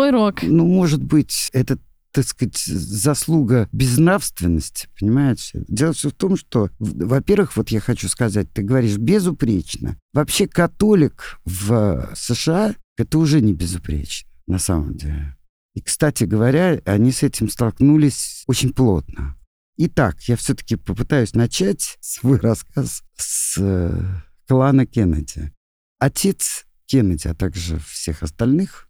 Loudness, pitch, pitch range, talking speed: -19 LUFS, 115 Hz, 90-150 Hz, 125 wpm